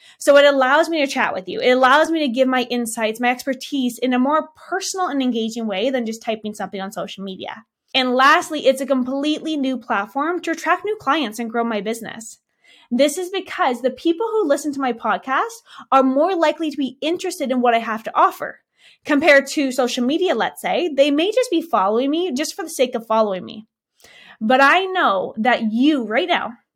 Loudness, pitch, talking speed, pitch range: -19 LUFS, 270 Hz, 210 wpm, 240-315 Hz